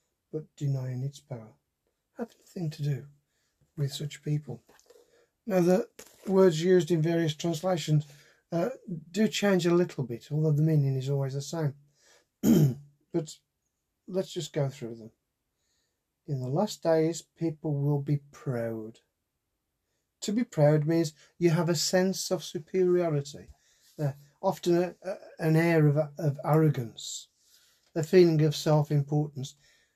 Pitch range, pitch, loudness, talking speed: 145-175 Hz, 155 Hz, -28 LUFS, 135 wpm